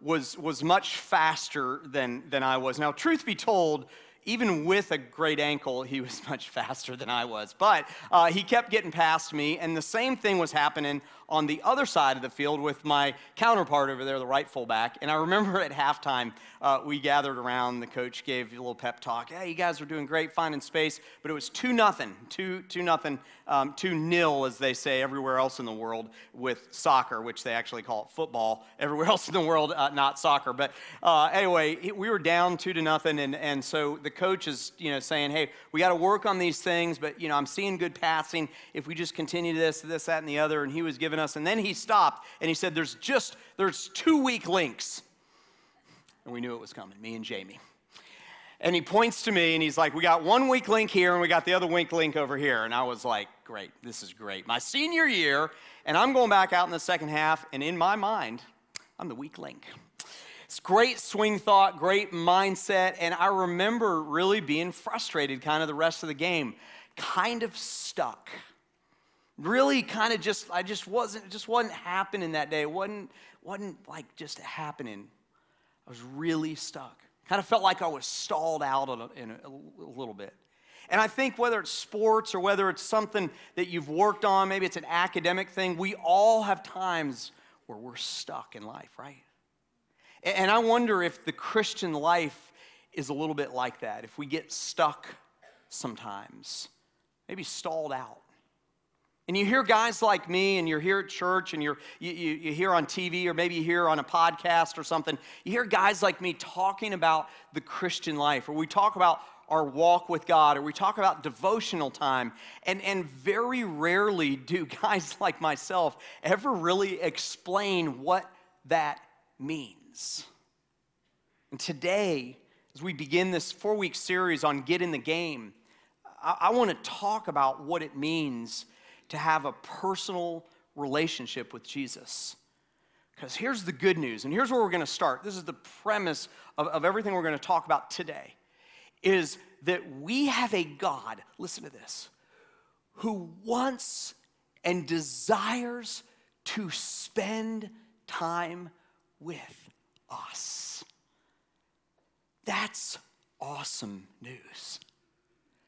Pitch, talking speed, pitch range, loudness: 170 Hz, 185 wpm, 150-195 Hz, -28 LUFS